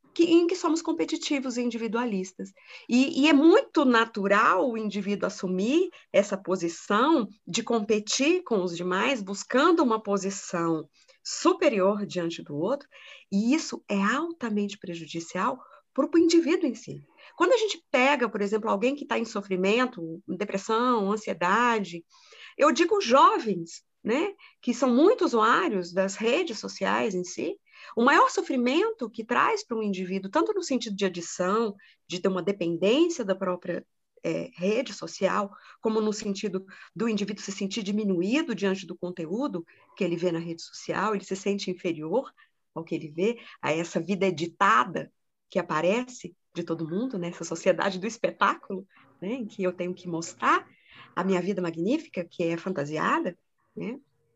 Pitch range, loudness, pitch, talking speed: 180-265 Hz, -26 LUFS, 205 Hz, 155 wpm